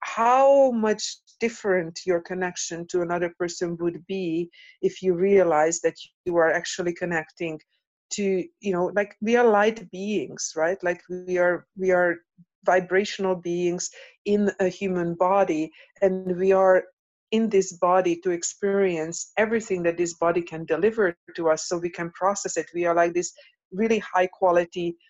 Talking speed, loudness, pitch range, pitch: 160 wpm, -24 LUFS, 170-195 Hz, 180 Hz